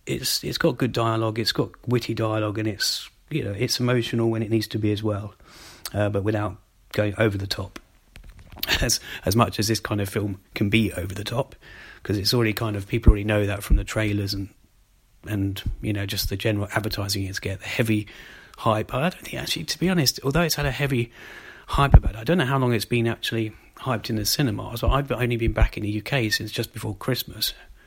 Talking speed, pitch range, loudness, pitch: 230 wpm, 100-120 Hz, -24 LUFS, 110 Hz